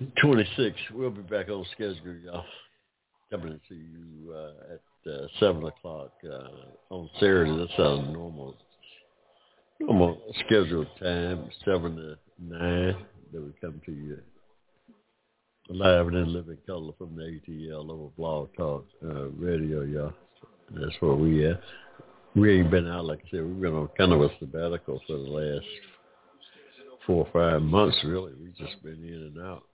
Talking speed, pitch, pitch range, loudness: 160 wpm, 85 Hz, 75-90 Hz, -27 LUFS